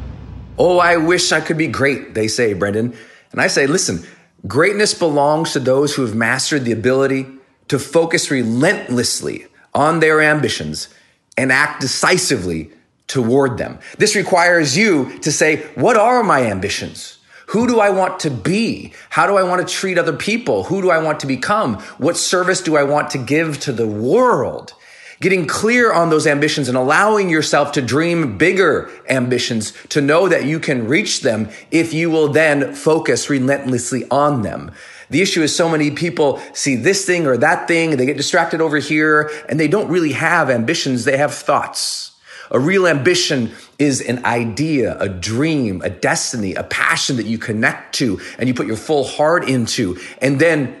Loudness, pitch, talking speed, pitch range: -16 LUFS, 150 Hz, 180 wpm, 130-170 Hz